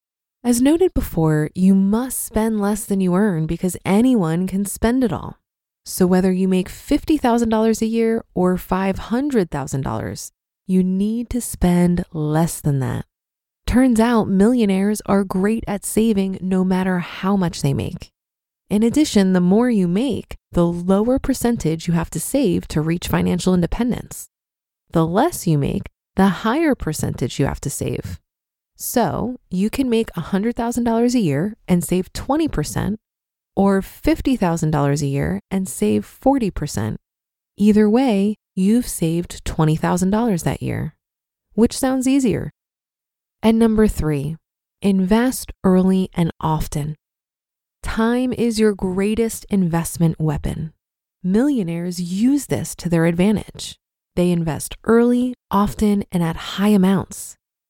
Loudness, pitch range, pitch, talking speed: -19 LUFS, 170-225 Hz, 195 Hz, 130 wpm